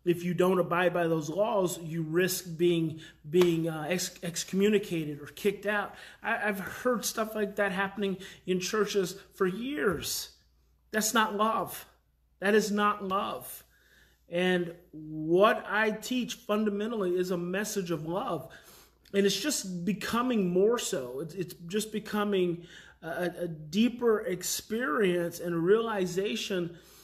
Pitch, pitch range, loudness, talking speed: 190 Hz, 175-210 Hz, -30 LUFS, 135 wpm